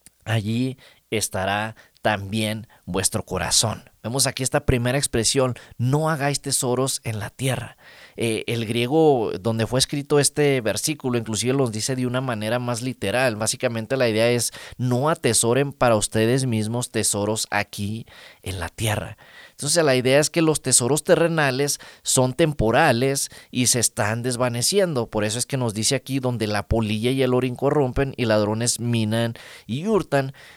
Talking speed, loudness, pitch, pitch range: 155 wpm, -22 LUFS, 125 Hz, 110-135 Hz